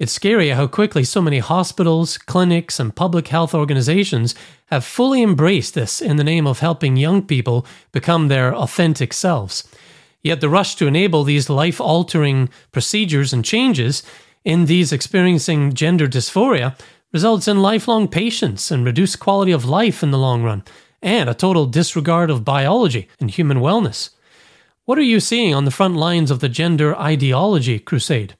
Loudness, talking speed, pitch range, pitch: -17 LUFS, 165 wpm, 140-185 Hz, 160 Hz